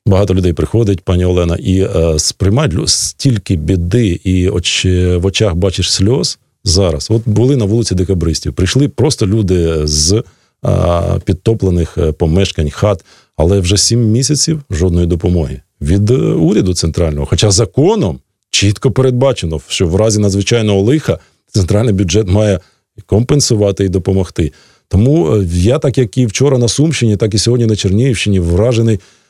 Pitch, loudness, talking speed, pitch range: 100 Hz, -12 LUFS, 140 wpm, 90-115 Hz